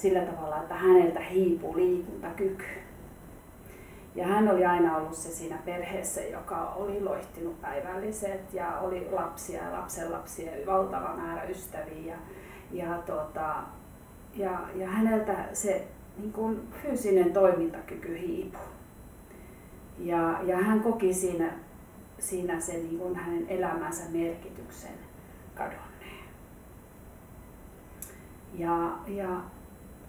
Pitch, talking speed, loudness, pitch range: 185 Hz, 100 wpm, -30 LUFS, 170-200 Hz